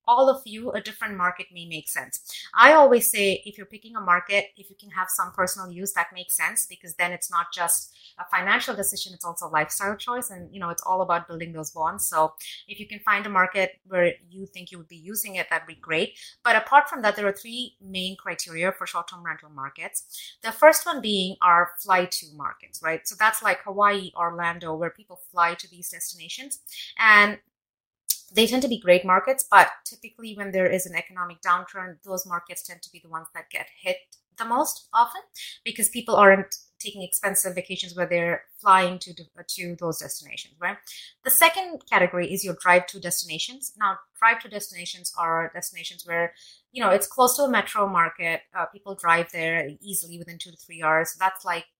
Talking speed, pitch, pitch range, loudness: 205 wpm, 185 Hz, 170-205 Hz, -23 LUFS